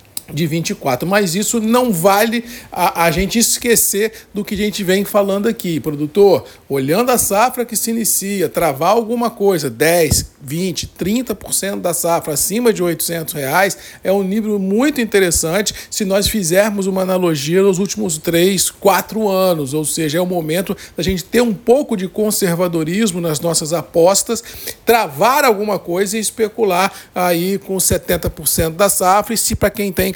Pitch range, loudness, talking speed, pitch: 170-215 Hz, -16 LUFS, 160 wpm, 195 Hz